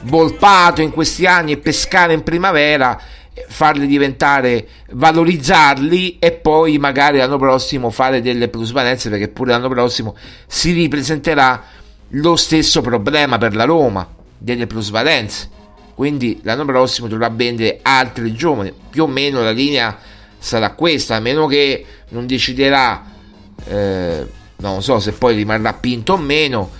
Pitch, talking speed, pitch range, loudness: 130 Hz, 135 wpm, 110-155 Hz, -14 LUFS